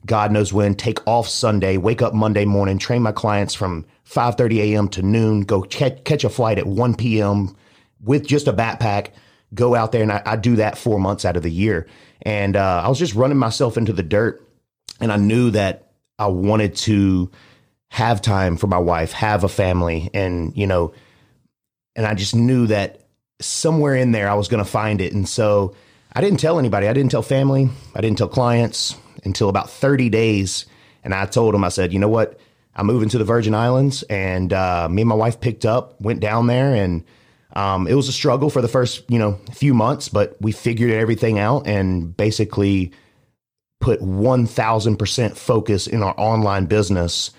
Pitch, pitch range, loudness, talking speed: 110 Hz, 100-120 Hz, -19 LUFS, 195 wpm